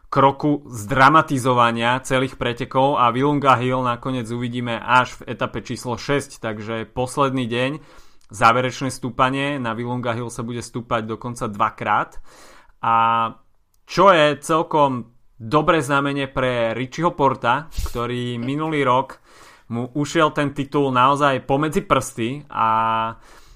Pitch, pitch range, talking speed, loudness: 125 Hz, 120-140 Hz, 120 wpm, -20 LUFS